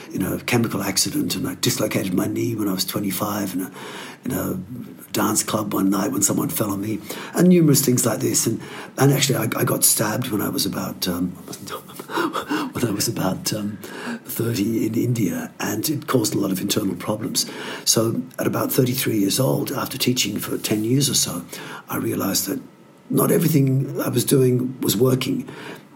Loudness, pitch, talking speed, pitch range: -21 LUFS, 115 Hz, 190 wpm, 100-135 Hz